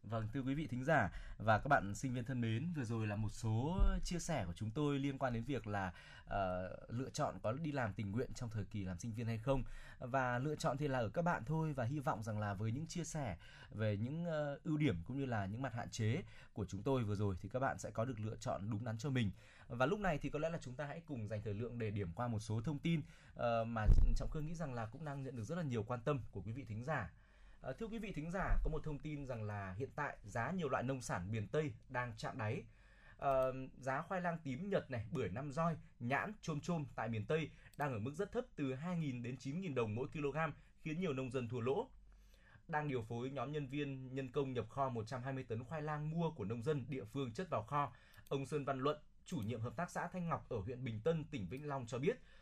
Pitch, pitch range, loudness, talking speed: 130 Hz, 110-150 Hz, -42 LUFS, 270 wpm